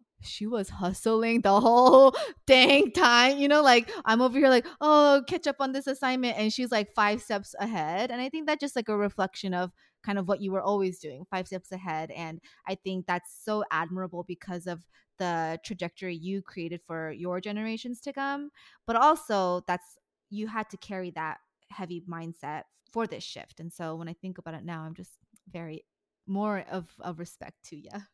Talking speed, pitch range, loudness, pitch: 195 wpm, 175-235 Hz, -26 LUFS, 200 Hz